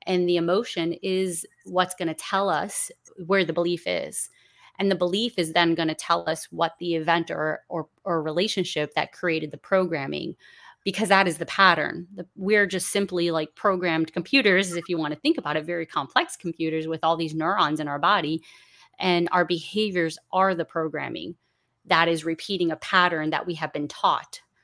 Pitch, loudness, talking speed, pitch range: 175 Hz, -24 LUFS, 190 wpm, 160-190 Hz